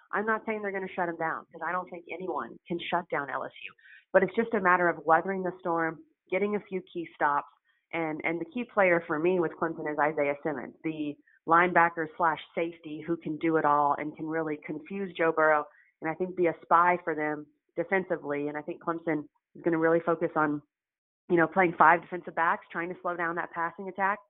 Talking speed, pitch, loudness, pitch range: 220 wpm, 170 Hz, -29 LUFS, 160-180 Hz